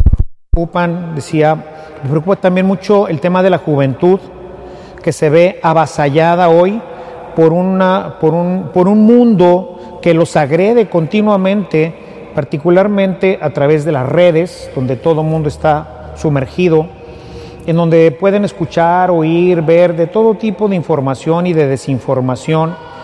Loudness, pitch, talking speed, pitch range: -12 LUFS, 170 Hz, 135 wpm, 155-185 Hz